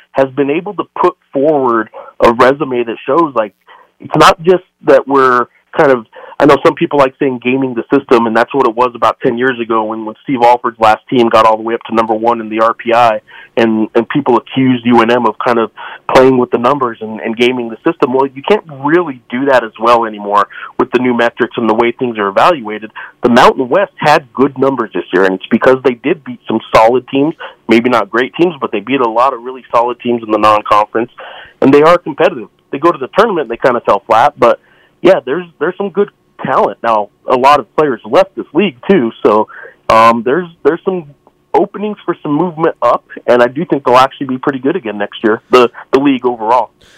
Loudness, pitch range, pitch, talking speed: -11 LUFS, 115-145 Hz, 125 Hz, 230 wpm